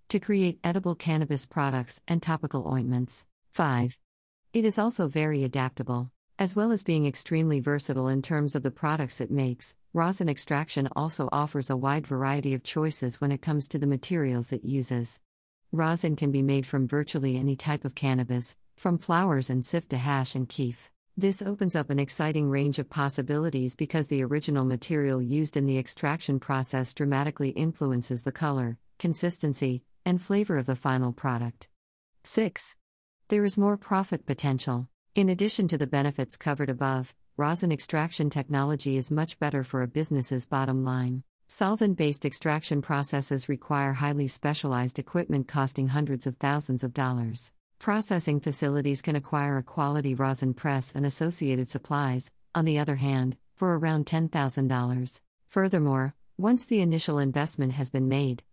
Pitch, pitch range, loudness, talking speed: 140 Hz, 130-155 Hz, -28 LUFS, 155 wpm